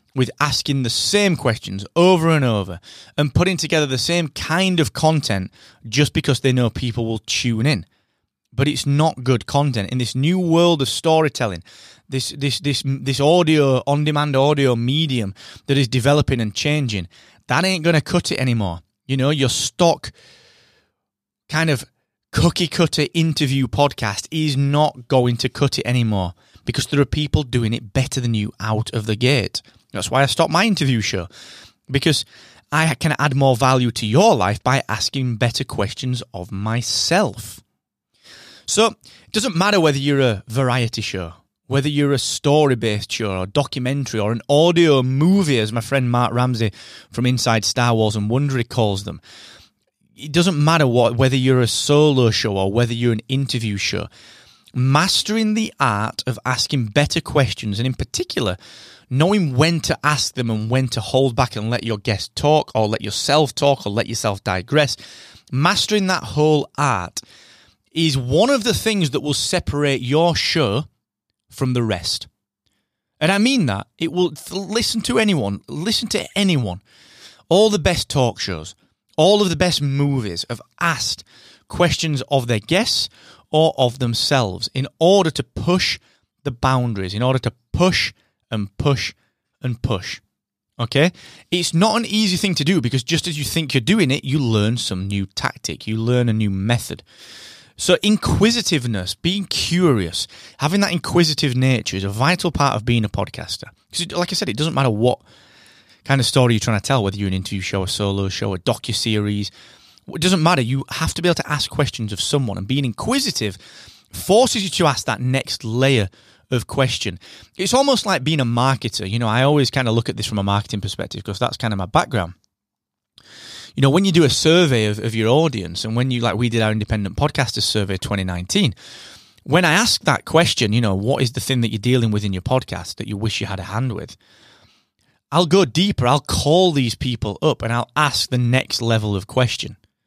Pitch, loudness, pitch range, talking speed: 130 Hz, -19 LUFS, 110-150 Hz, 185 wpm